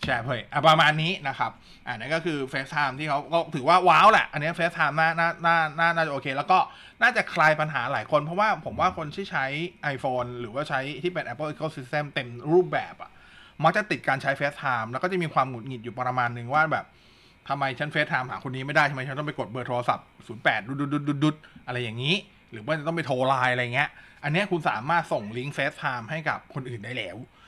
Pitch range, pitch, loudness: 130-160 Hz, 145 Hz, -25 LUFS